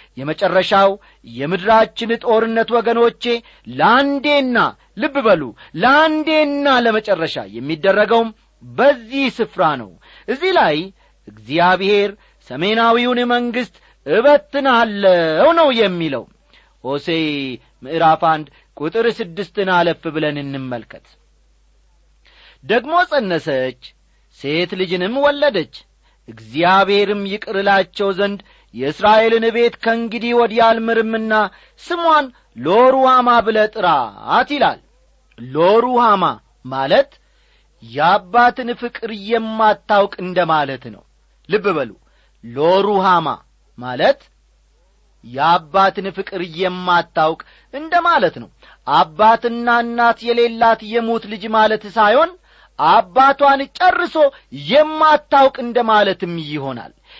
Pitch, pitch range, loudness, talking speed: 220 Hz, 175-240 Hz, -15 LUFS, 80 wpm